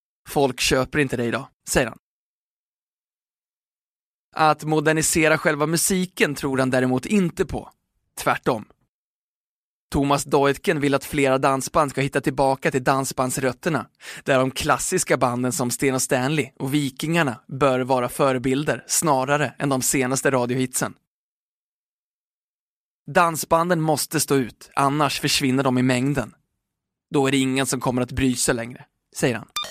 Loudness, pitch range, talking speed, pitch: -21 LUFS, 130-150 Hz, 135 wpm, 140 Hz